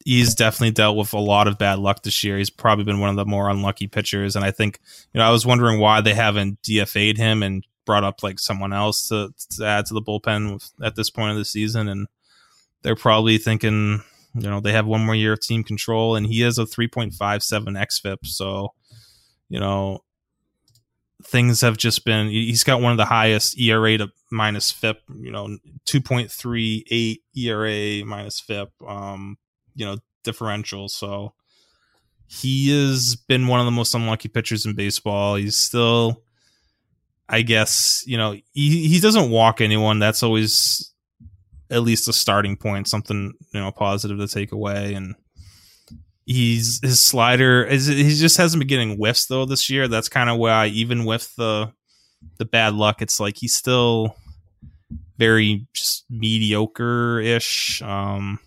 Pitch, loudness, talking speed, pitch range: 110 Hz, -19 LUFS, 170 wpm, 100-115 Hz